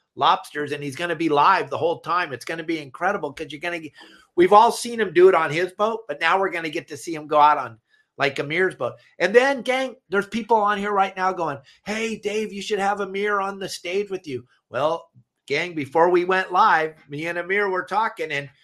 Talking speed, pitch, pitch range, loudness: 250 wpm, 185 Hz, 160-205 Hz, -22 LUFS